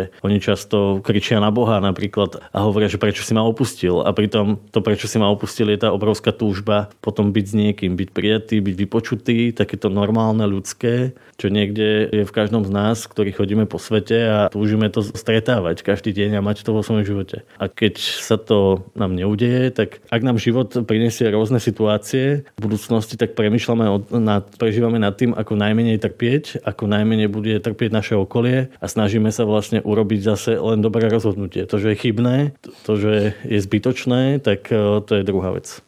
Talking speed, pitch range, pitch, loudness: 180 wpm, 105-115 Hz, 110 Hz, -19 LUFS